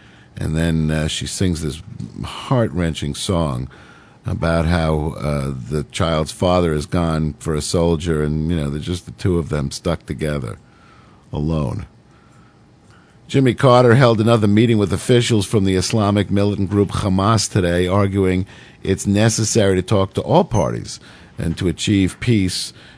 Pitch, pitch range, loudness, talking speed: 90 Hz, 80-105 Hz, -18 LUFS, 150 wpm